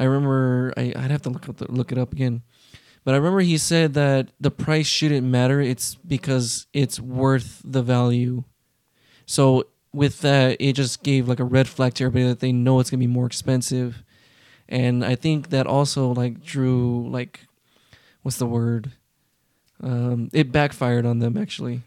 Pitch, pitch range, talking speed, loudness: 130 Hz, 125-140 Hz, 175 wpm, -22 LUFS